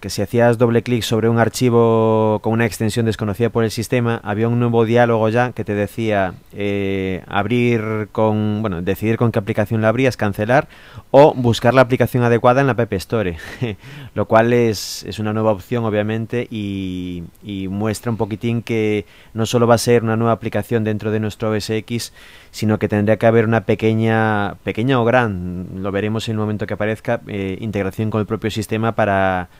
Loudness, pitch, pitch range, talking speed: -18 LUFS, 110 Hz, 105-115 Hz, 185 wpm